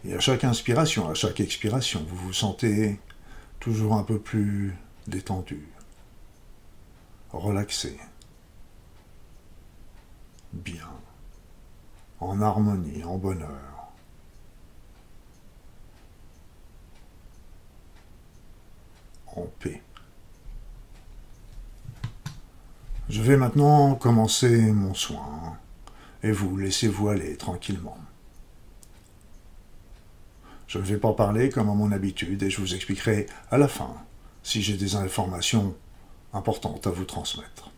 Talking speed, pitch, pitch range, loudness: 90 wpm, 100 Hz, 90-110 Hz, -26 LUFS